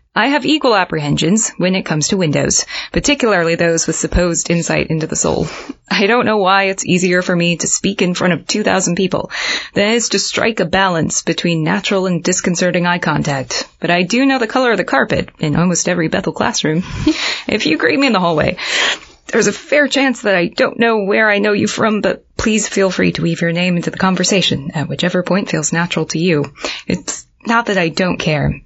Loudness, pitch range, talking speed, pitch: -15 LUFS, 170-210 Hz, 215 wpm, 185 Hz